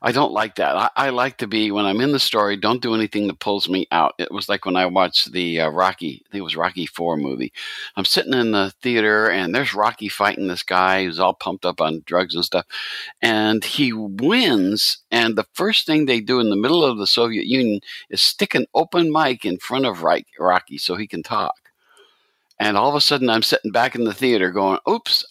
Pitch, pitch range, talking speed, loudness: 105 Hz, 95-125 Hz, 230 wpm, -19 LUFS